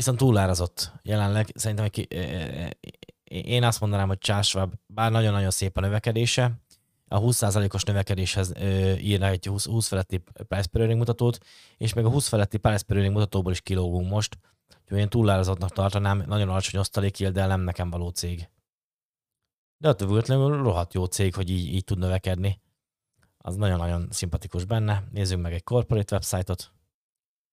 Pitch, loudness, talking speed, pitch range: 100 Hz, -26 LUFS, 155 wpm, 95-110 Hz